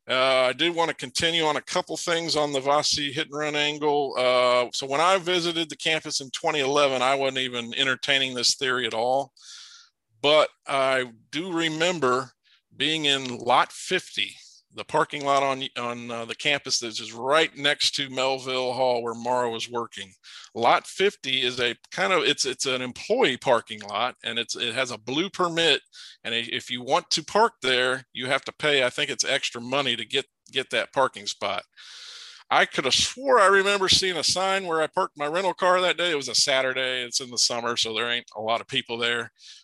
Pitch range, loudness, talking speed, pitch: 120-155 Hz, -24 LUFS, 205 wpm, 135 Hz